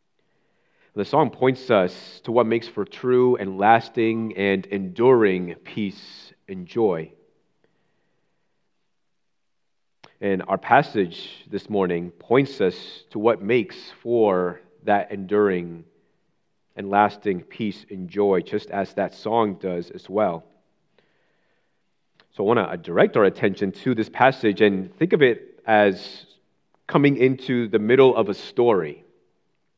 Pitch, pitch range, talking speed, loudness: 105 Hz, 95-115 Hz, 125 wpm, -21 LUFS